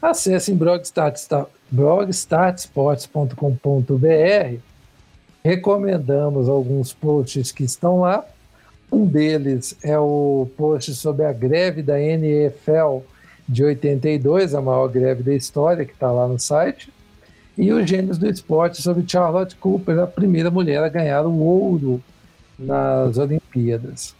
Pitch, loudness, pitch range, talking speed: 150 Hz, -19 LUFS, 135-175 Hz, 125 wpm